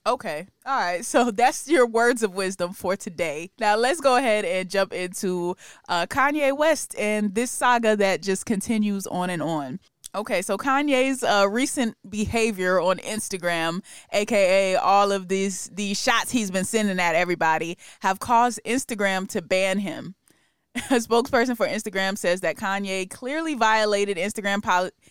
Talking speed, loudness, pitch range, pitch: 160 wpm, -23 LUFS, 185-240 Hz, 205 Hz